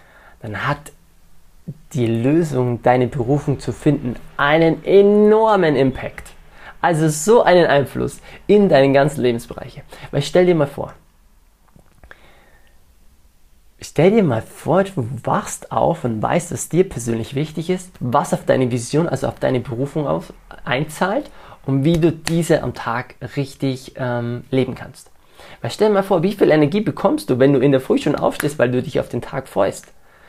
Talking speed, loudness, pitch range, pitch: 160 wpm, -18 LUFS, 120-165 Hz, 135 Hz